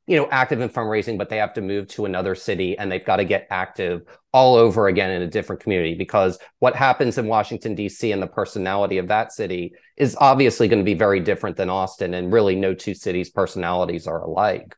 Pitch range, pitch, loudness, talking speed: 90-110 Hz, 95 Hz, -21 LUFS, 225 wpm